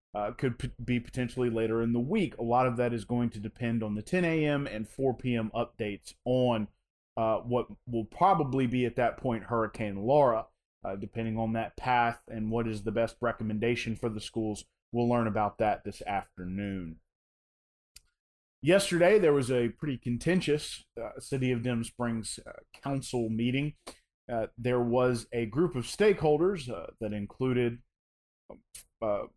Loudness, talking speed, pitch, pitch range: -30 LUFS, 165 wpm, 120 Hz, 110-125 Hz